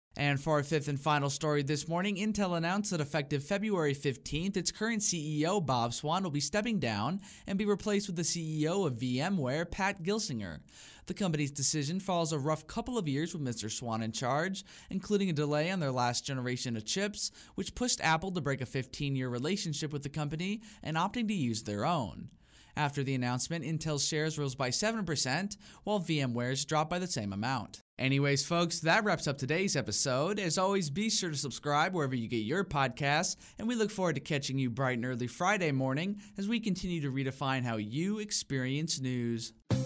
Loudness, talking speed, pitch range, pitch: -33 LUFS, 195 wpm, 135-190 Hz, 155 Hz